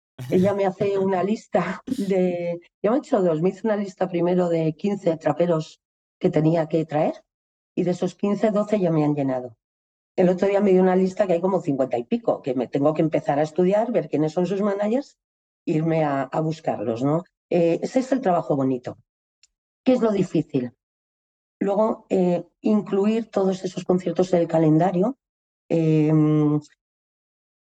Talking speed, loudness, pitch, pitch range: 180 wpm, -22 LUFS, 175 Hz, 155-200 Hz